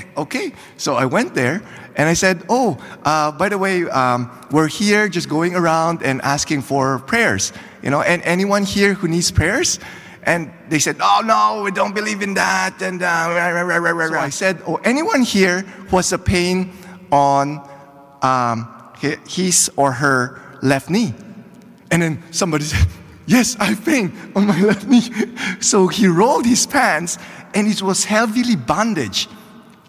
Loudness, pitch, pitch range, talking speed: -17 LUFS, 185 Hz, 150-205 Hz, 165 wpm